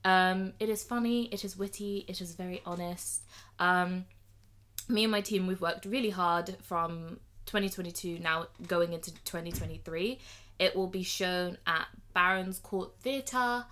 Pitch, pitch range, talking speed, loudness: 180 Hz, 170-200 Hz, 150 wpm, -32 LUFS